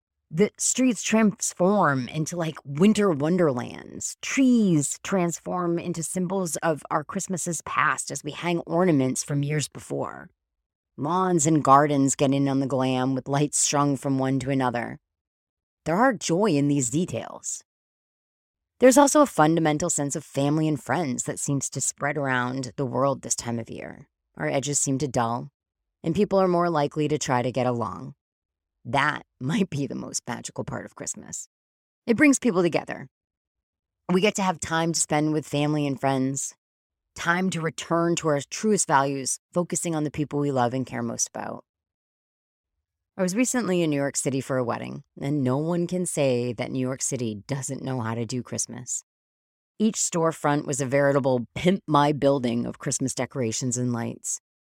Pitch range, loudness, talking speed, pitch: 125-170 Hz, -24 LUFS, 170 wpm, 145 Hz